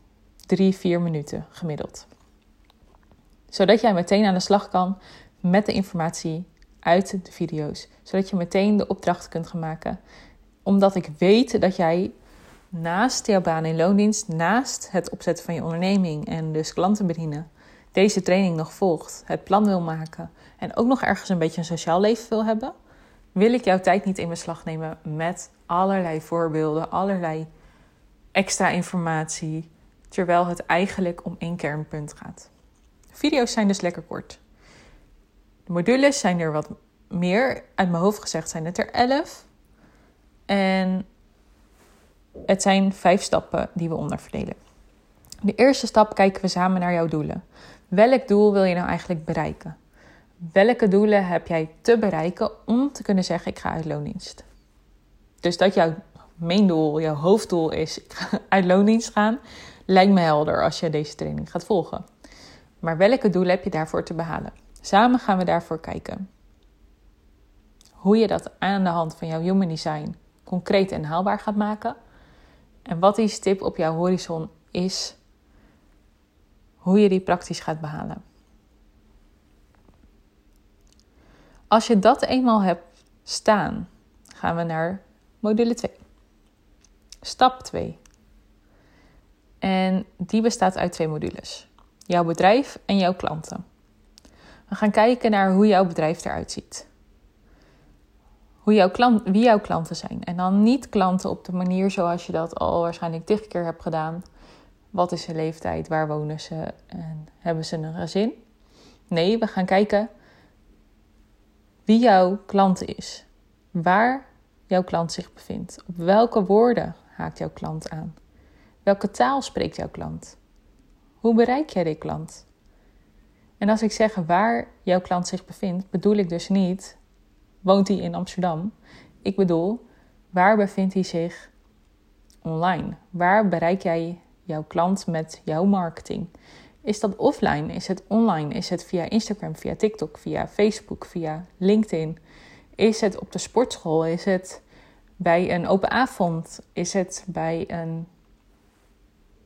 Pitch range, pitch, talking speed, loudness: 160-205 Hz, 180 Hz, 150 wpm, -23 LUFS